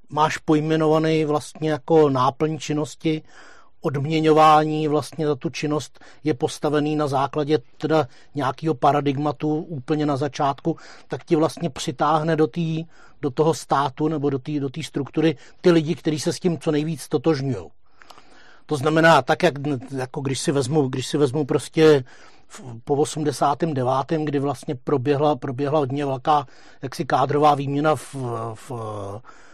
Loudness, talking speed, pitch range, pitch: -22 LUFS, 140 wpm, 140-155 Hz, 150 Hz